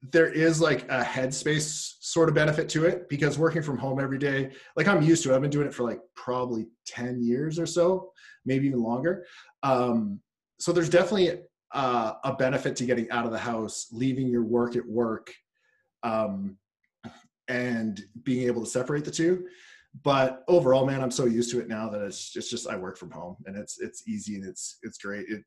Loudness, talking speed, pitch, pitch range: -27 LUFS, 210 wpm, 130 Hz, 120-160 Hz